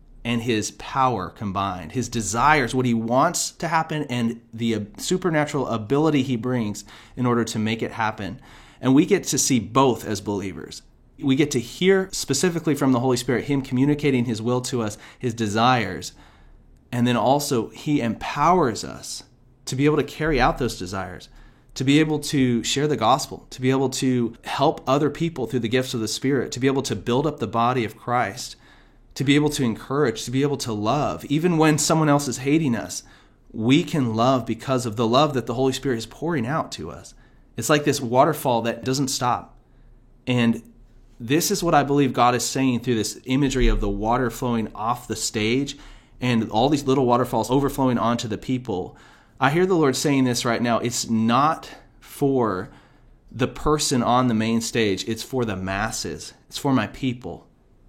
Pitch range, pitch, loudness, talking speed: 115-140 Hz, 125 Hz, -22 LUFS, 190 wpm